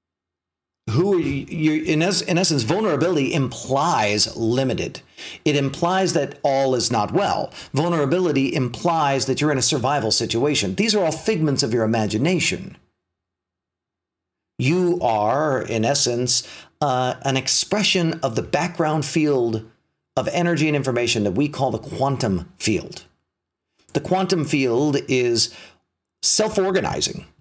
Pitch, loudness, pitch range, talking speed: 135 Hz, -20 LUFS, 115-160 Hz, 125 wpm